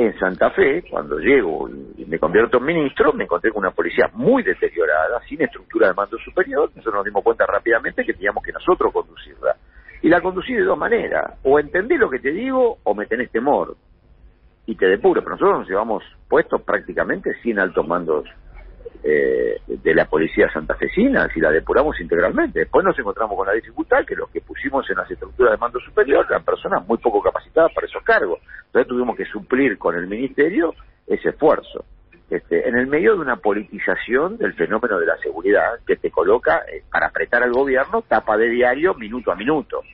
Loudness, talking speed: -19 LUFS, 190 wpm